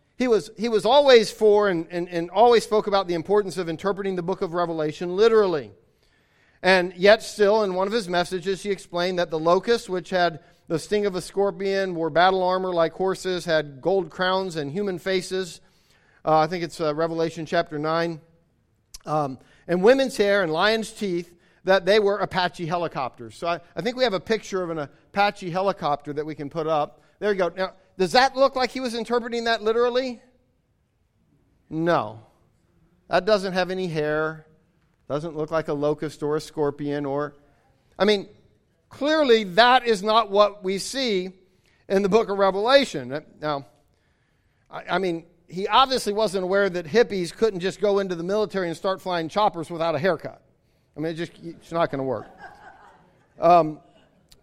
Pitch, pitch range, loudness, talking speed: 185 Hz, 165-205 Hz, -23 LUFS, 180 wpm